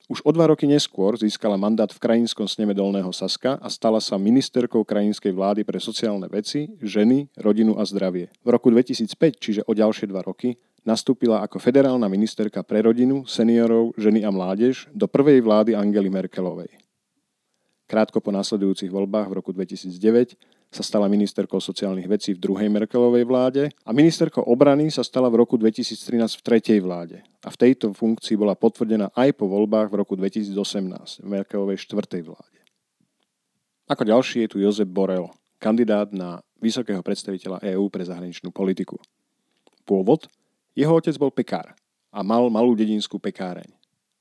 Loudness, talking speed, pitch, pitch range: -21 LUFS, 155 wpm, 110 Hz, 100-120 Hz